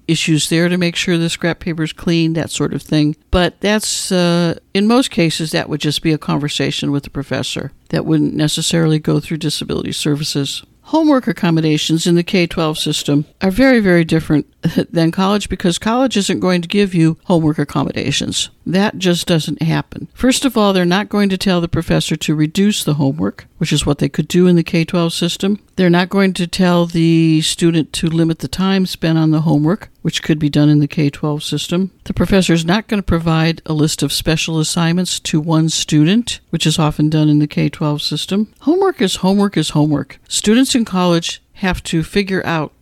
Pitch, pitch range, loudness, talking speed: 165 Hz, 155-185 Hz, -15 LUFS, 205 wpm